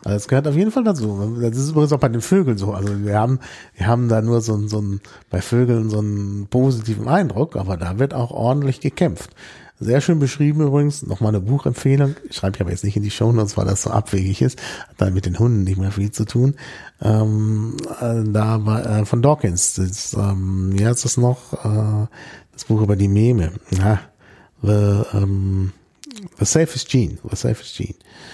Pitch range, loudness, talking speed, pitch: 100-130 Hz, -19 LUFS, 200 wpm, 110 Hz